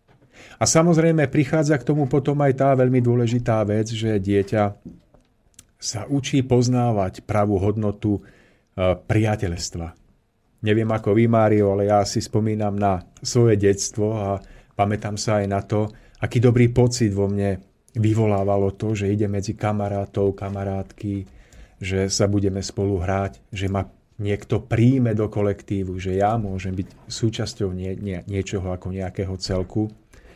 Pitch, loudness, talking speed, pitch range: 105 Hz, -22 LUFS, 135 wpm, 100-115 Hz